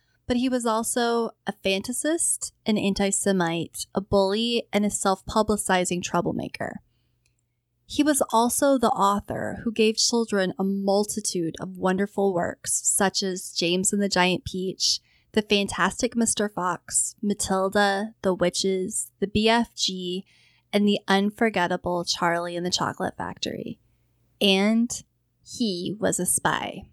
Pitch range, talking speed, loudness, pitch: 180-215 Hz, 130 wpm, -24 LUFS, 195 Hz